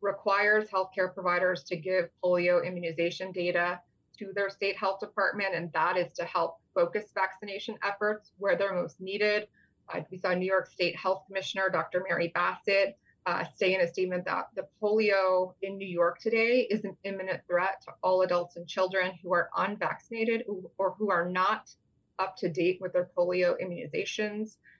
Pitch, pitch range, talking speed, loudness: 190 Hz, 180-200 Hz, 170 wpm, -30 LUFS